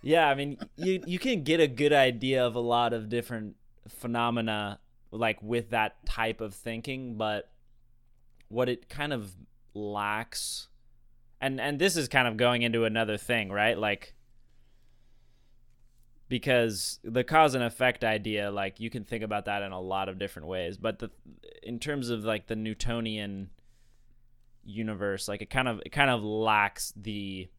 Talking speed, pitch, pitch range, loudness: 165 wpm, 120 Hz, 110-120 Hz, -29 LUFS